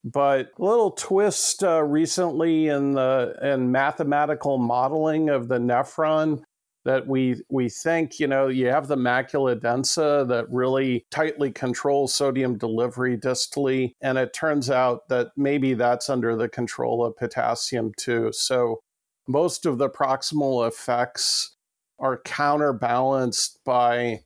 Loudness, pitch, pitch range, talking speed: -23 LUFS, 130 Hz, 125-145 Hz, 135 wpm